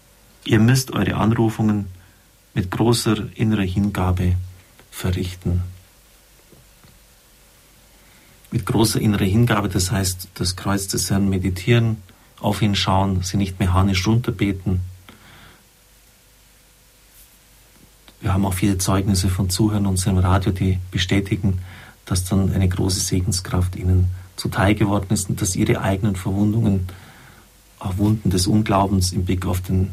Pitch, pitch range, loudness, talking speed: 100 Hz, 95-110 Hz, -20 LUFS, 120 wpm